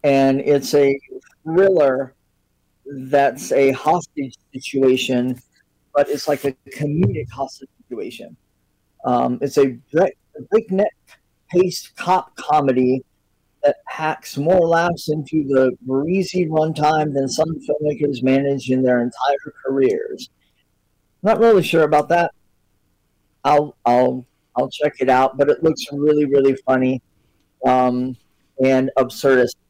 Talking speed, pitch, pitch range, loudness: 115 wpm, 140 Hz, 130-155 Hz, -18 LUFS